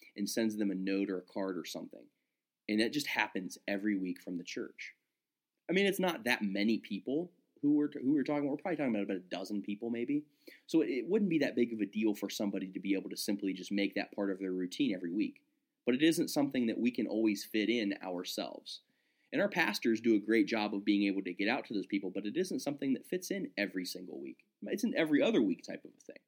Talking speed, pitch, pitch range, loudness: 255 wpm, 105 Hz, 100-150 Hz, -34 LUFS